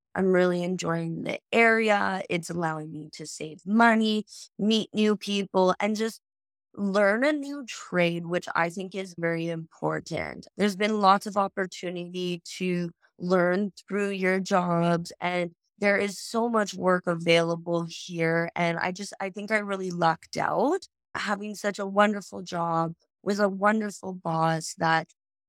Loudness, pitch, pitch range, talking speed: -26 LUFS, 185 Hz, 170-205 Hz, 150 wpm